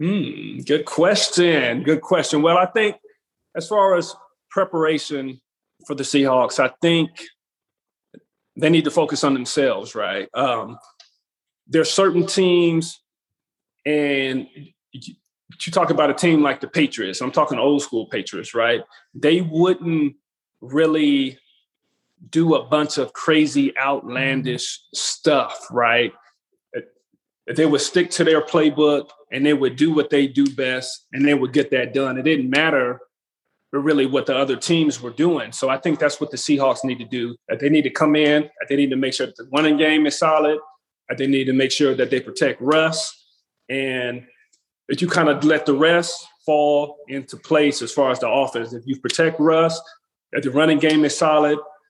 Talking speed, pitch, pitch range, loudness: 175 wpm, 150 Hz, 135-160 Hz, -19 LUFS